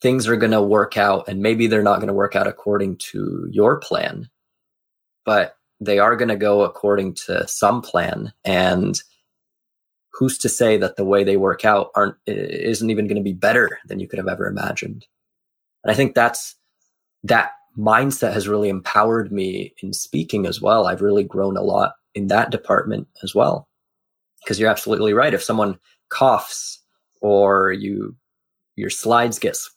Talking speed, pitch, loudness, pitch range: 175 wpm, 105 Hz, -19 LUFS, 100-115 Hz